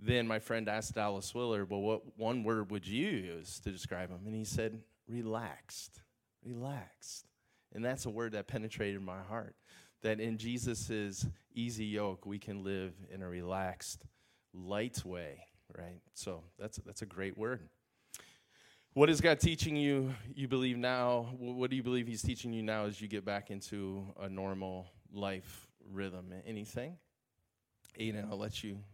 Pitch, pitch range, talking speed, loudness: 110 Hz, 100-120 Hz, 165 wpm, -38 LUFS